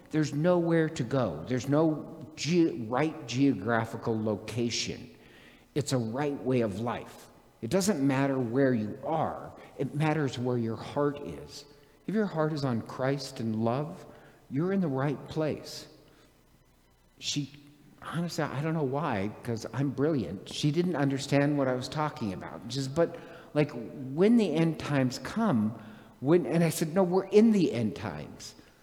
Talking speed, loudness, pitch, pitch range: 160 wpm, -29 LUFS, 140 Hz, 120-155 Hz